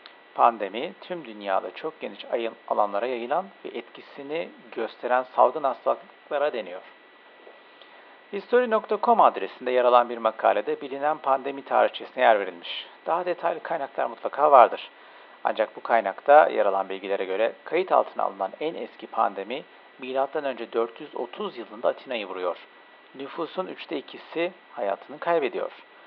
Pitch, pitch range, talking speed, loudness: 150 Hz, 125-185 Hz, 120 wpm, -25 LUFS